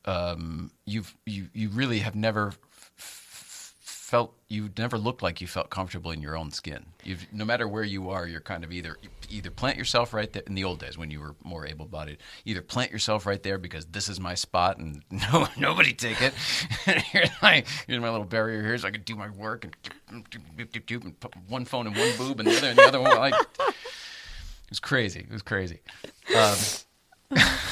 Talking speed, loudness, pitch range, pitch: 215 wpm, -25 LUFS, 85-115 Hz, 105 Hz